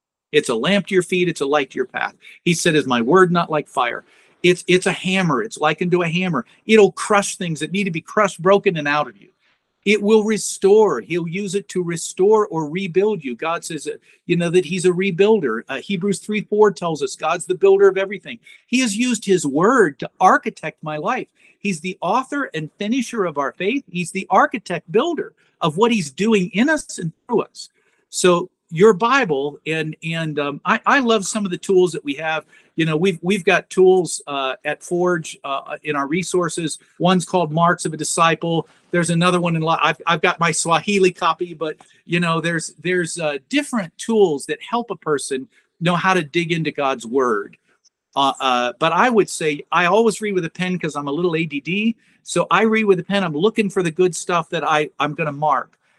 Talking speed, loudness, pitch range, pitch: 215 wpm, -19 LUFS, 160-200 Hz, 180 Hz